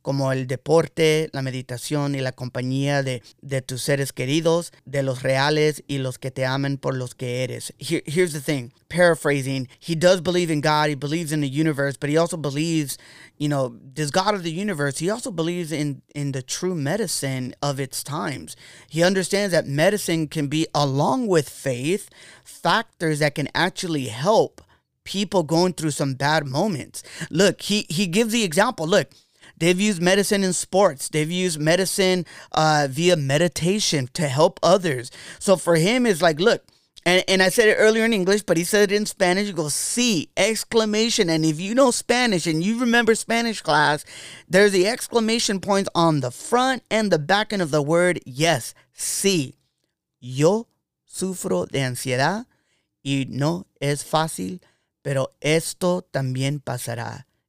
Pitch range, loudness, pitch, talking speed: 140-185 Hz, -22 LUFS, 160 Hz, 175 wpm